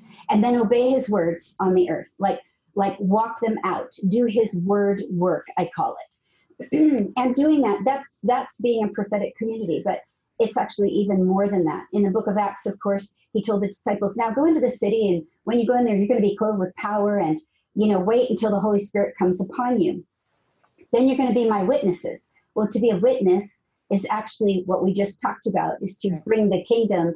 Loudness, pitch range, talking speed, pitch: -22 LUFS, 195-235 Hz, 220 wpm, 210 Hz